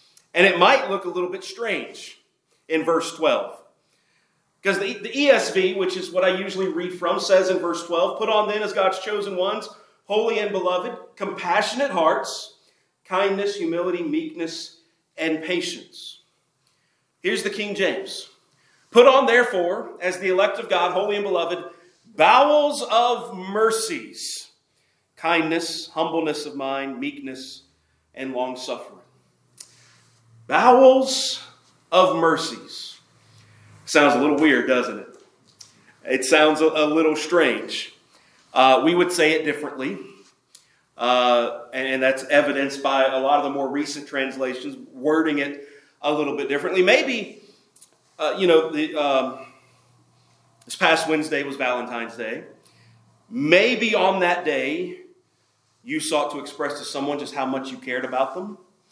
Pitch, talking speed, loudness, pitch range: 165 Hz, 140 wpm, -21 LUFS, 140-195 Hz